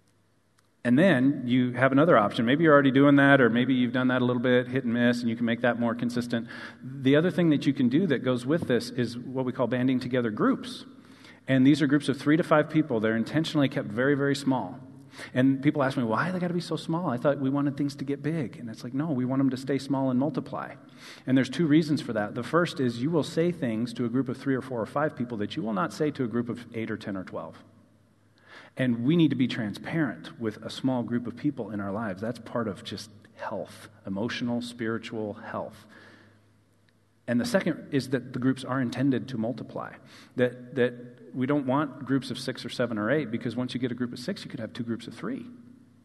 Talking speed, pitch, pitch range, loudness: 250 wpm, 125 Hz, 120-140 Hz, -27 LUFS